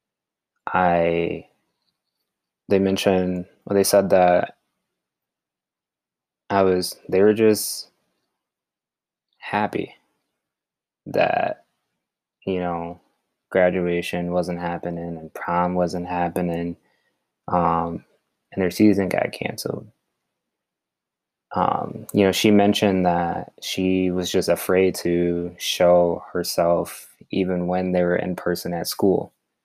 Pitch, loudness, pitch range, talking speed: 90 Hz, -21 LUFS, 85-95 Hz, 100 wpm